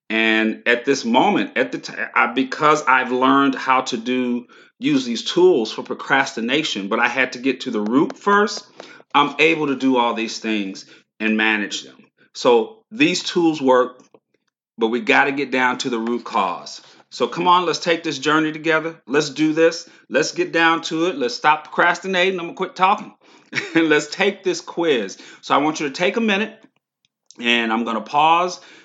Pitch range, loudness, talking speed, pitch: 125-175 Hz, -19 LUFS, 190 wpm, 150 Hz